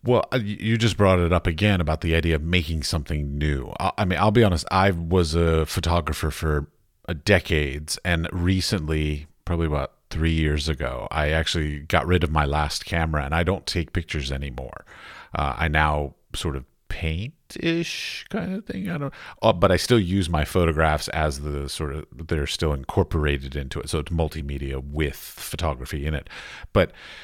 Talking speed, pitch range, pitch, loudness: 180 wpm, 75-95 Hz, 80 Hz, -24 LUFS